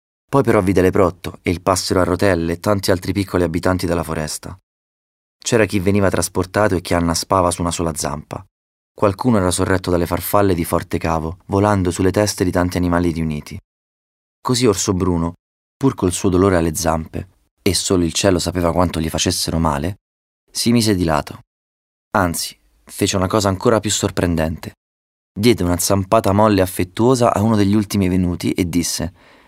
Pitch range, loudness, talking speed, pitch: 85-100 Hz, -18 LUFS, 170 wpm, 90 Hz